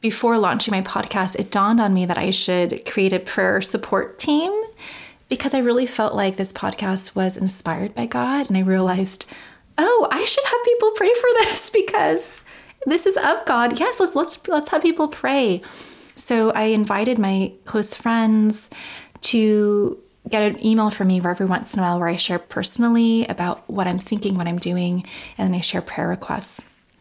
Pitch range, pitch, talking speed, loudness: 190-275 Hz, 215 Hz, 185 wpm, -19 LUFS